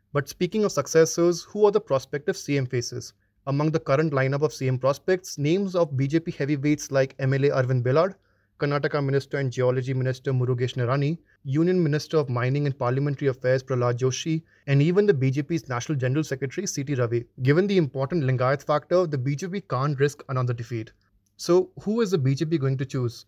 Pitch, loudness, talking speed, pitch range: 140 Hz, -25 LUFS, 180 wpm, 130-160 Hz